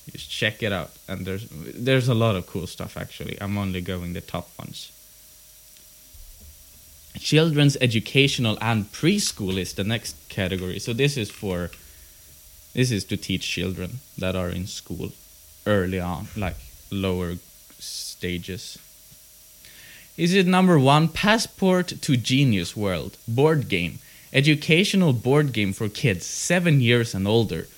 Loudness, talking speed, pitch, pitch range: -23 LUFS, 140 wpm, 100 Hz, 90-135 Hz